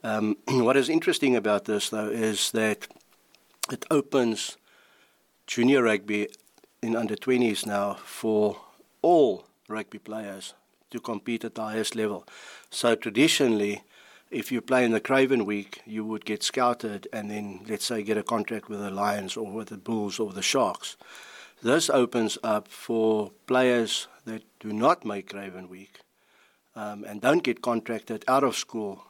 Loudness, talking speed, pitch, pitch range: -26 LUFS, 155 wpm, 110 Hz, 105-115 Hz